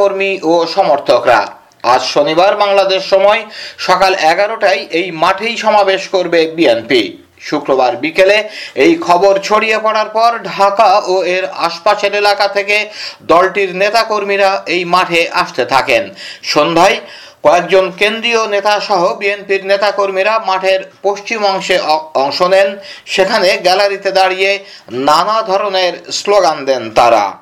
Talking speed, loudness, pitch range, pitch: 115 wpm, -12 LUFS, 185-205 Hz, 195 Hz